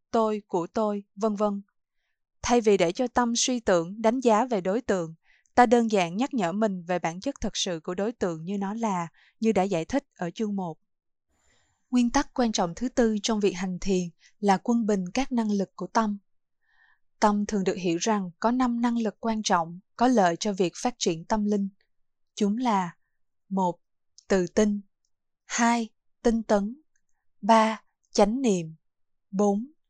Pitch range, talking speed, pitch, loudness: 190-235 Hz, 180 wpm, 210 Hz, -26 LUFS